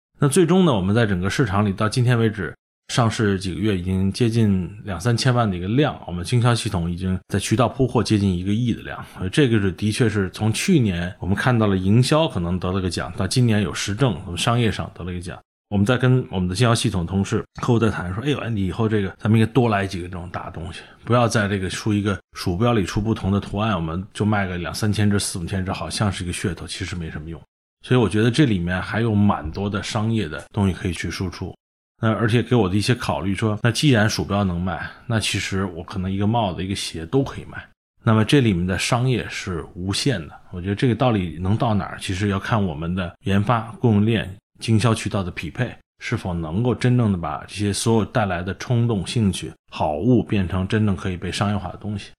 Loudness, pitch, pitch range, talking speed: -21 LUFS, 100 Hz, 95-115 Hz, 350 characters per minute